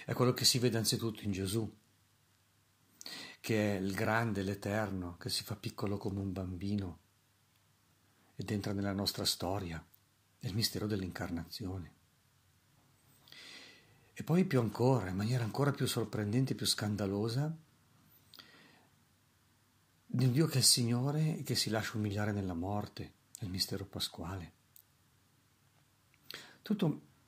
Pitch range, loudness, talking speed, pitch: 100-125 Hz, -34 LUFS, 125 wpm, 105 Hz